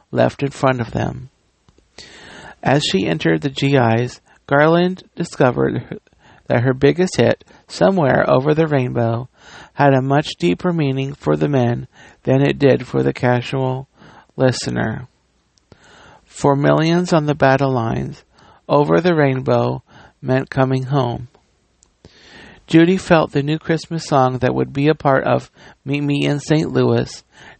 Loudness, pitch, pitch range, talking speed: -17 LUFS, 135 Hz, 125-145 Hz, 145 wpm